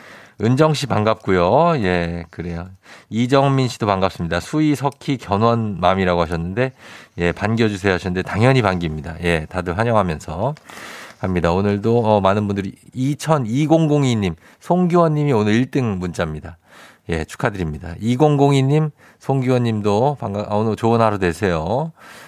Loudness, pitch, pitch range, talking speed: -19 LUFS, 105 Hz, 90-130 Hz, 295 characters per minute